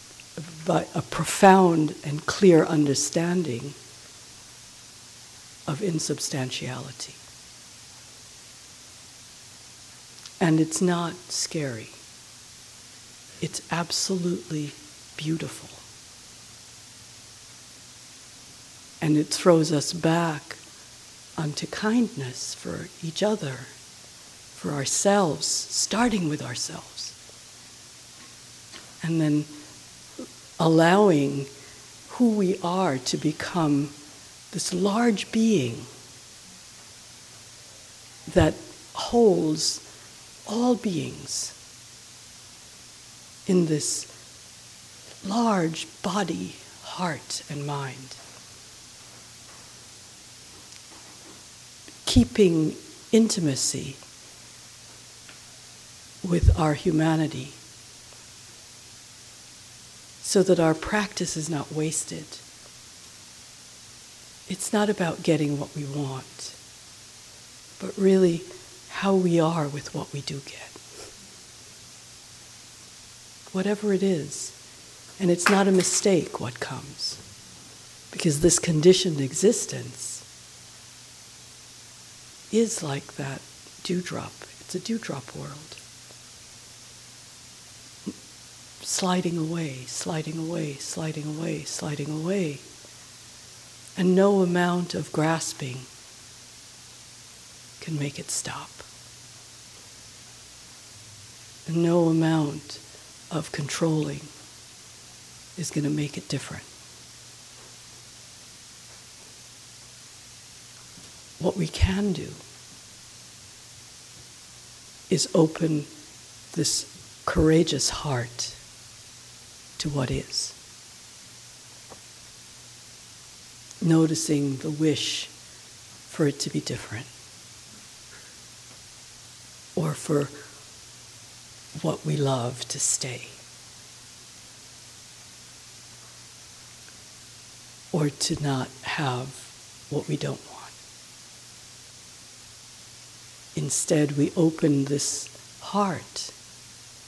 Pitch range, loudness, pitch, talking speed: 130-175 Hz, -25 LUFS, 155 Hz, 70 wpm